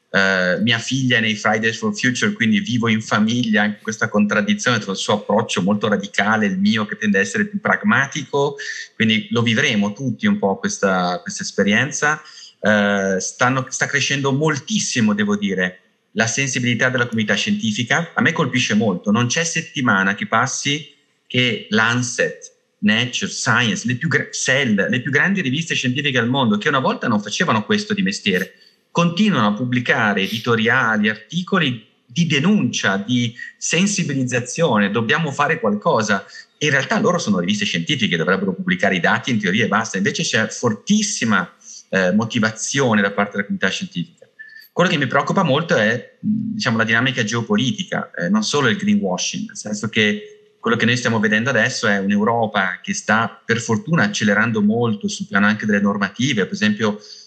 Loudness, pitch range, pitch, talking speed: -18 LUFS, 105-170 Hz, 125 Hz, 165 wpm